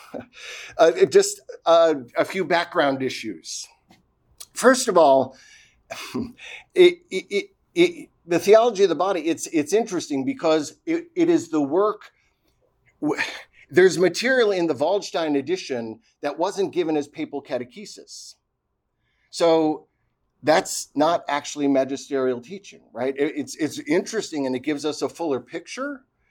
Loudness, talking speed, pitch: -22 LUFS, 135 wpm, 170 Hz